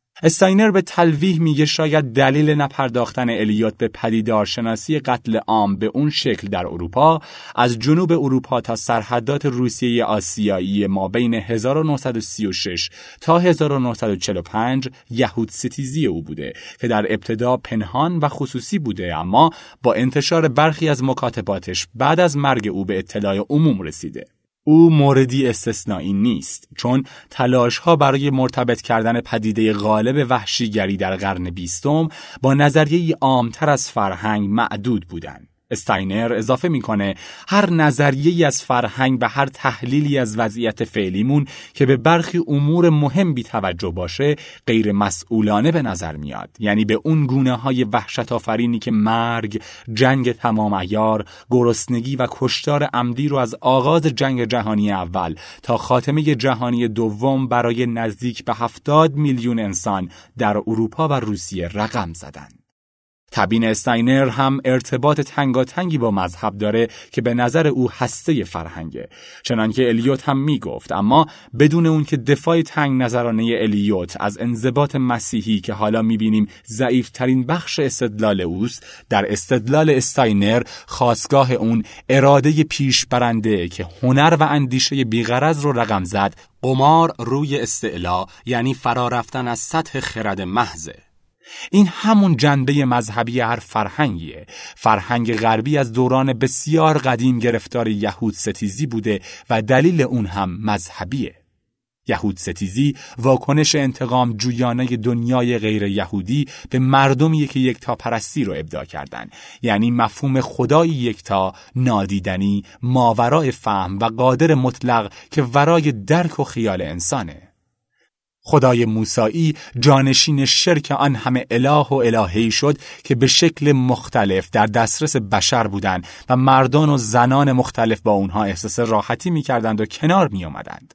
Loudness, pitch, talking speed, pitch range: -18 LUFS, 120 Hz, 135 wpm, 110-140 Hz